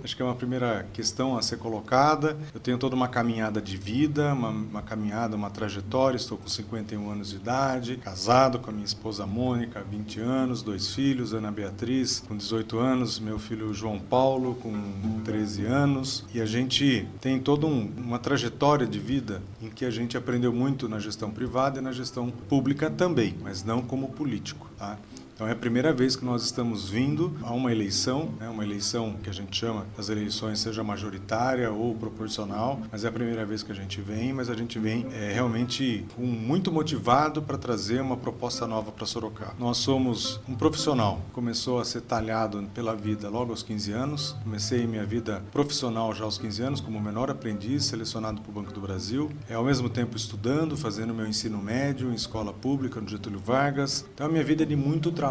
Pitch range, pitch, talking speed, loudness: 110-130 Hz, 115 Hz, 195 wpm, -28 LUFS